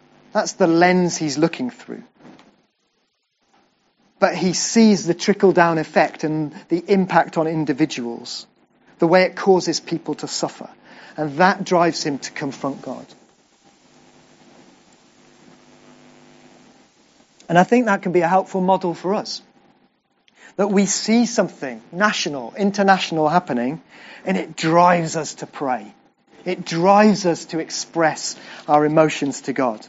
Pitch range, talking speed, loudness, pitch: 155-190 Hz, 130 wpm, -19 LUFS, 170 Hz